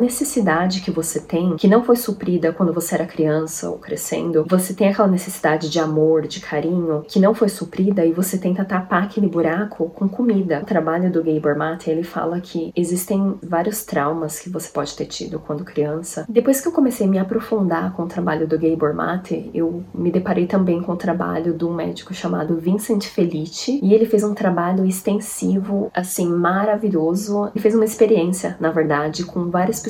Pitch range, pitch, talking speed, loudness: 165-205 Hz, 175 Hz, 190 wpm, -20 LUFS